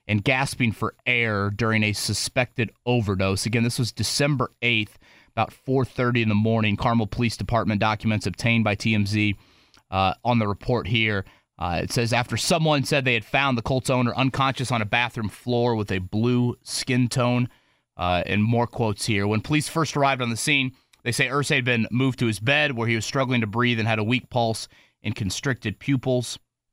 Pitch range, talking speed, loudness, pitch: 105-125 Hz, 195 wpm, -23 LUFS, 120 Hz